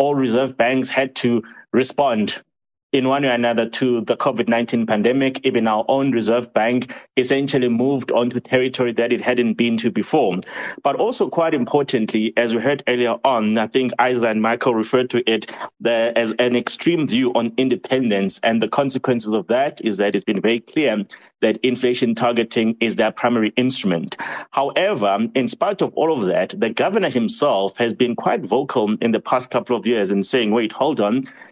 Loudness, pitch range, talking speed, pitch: -19 LUFS, 115-130 Hz, 185 wpm, 120 Hz